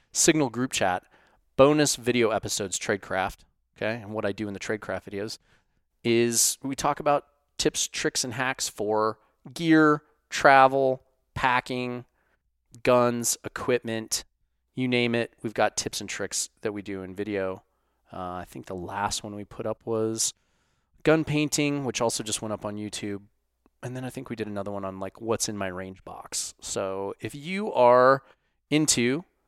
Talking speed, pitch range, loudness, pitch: 165 wpm, 105-135 Hz, -26 LUFS, 115 Hz